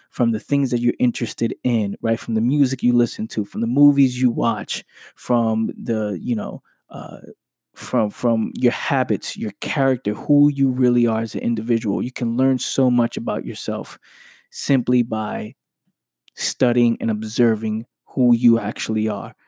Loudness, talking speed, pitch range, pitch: -20 LUFS, 165 wpm, 110-130 Hz, 120 Hz